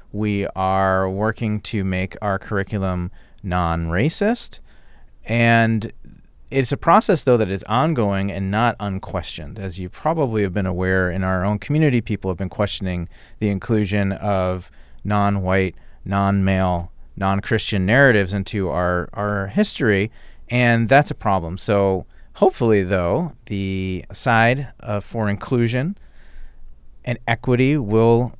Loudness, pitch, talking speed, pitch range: -20 LUFS, 100 Hz, 135 wpm, 95-115 Hz